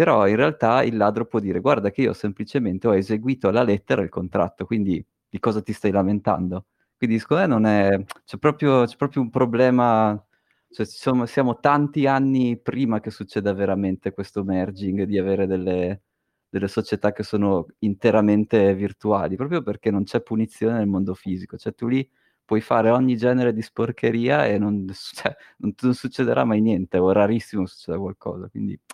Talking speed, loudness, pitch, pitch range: 180 wpm, -22 LUFS, 105 Hz, 100-120 Hz